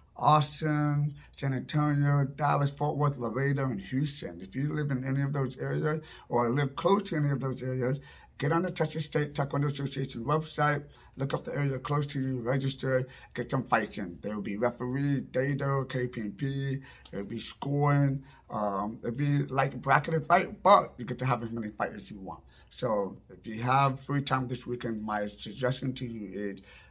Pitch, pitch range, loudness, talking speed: 135 Hz, 120-145 Hz, -30 LUFS, 195 wpm